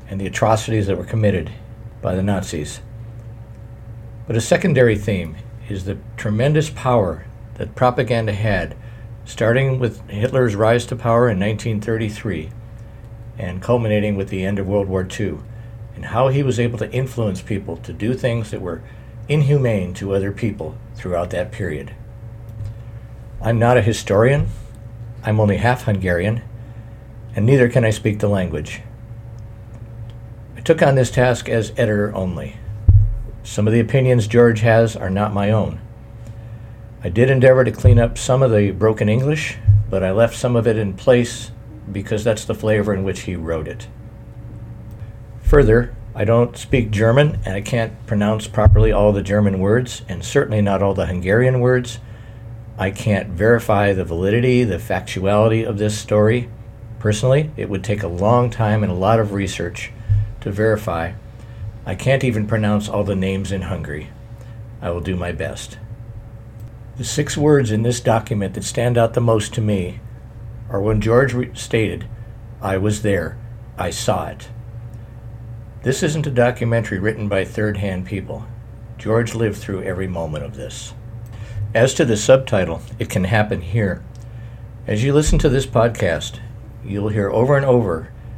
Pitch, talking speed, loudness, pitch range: 115 Hz, 160 wpm, -18 LUFS, 105-115 Hz